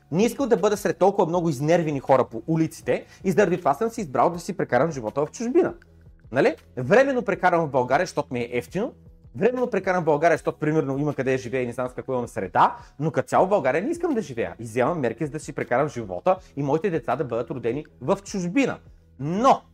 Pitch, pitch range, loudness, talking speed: 155 Hz, 125-185 Hz, -24 LUFS, 225 wpm